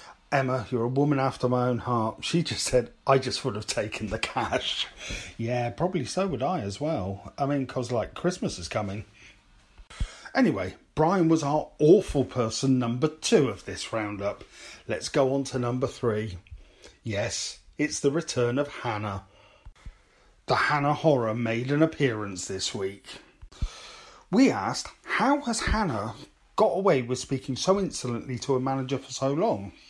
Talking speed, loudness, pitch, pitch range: 160 wpm, -27 LUFS, 130 Hz, 110-150 Hz